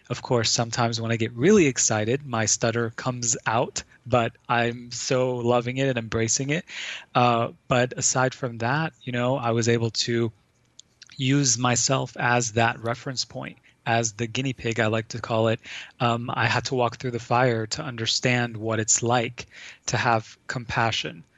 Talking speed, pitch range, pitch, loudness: 175 wpm, 115-130 Hz, 120 Hz, -24 LUFS